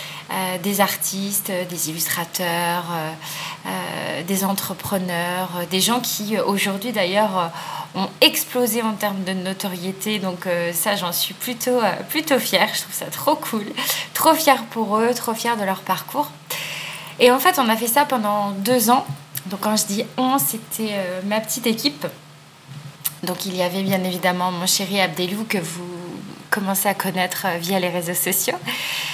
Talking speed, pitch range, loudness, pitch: 165 wpm, 180-220 Hz, -21 LUFS, 195 Hz